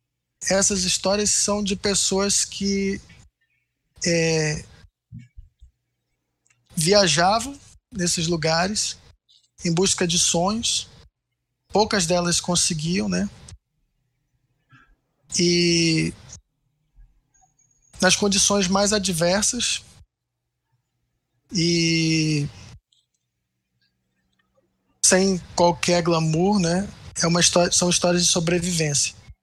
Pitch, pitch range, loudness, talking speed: 165 Hz, 125-185 Hz, -20 LUFS, 70 wpm